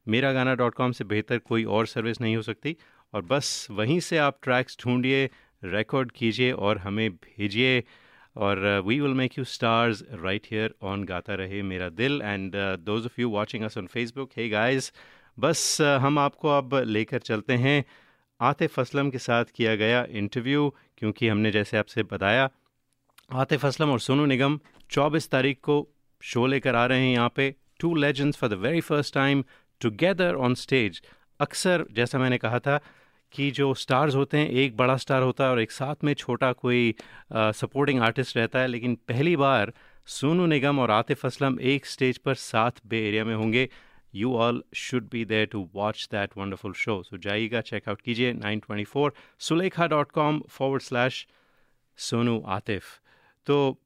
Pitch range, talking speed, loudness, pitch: 110-140 Hz, 175 wpm, -26 LUFS, 125 Hz